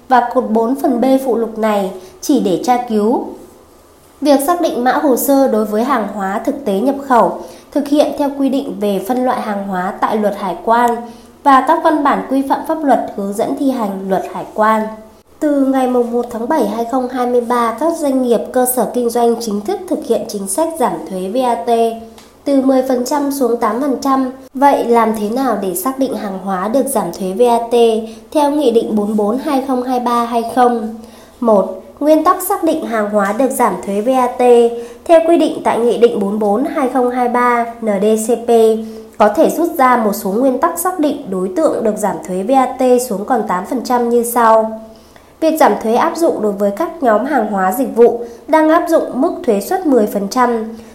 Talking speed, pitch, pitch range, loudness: 190 wpm, 240 Hz, 220-270 Hz, -14 LUFS